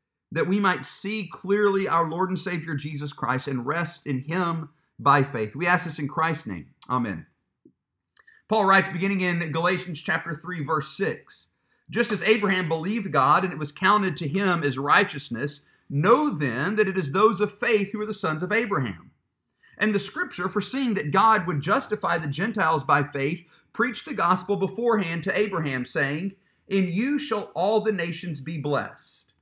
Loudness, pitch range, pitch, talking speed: -24 LUFS, 155-205 Hz, 180 Hz, 175 wpm